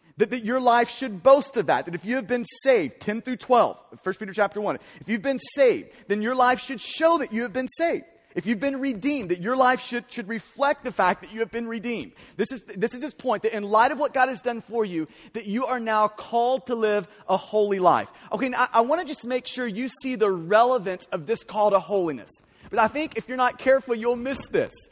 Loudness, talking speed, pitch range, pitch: -24 LUFS, 255 wpm, 210-260 Hz, 240 Hz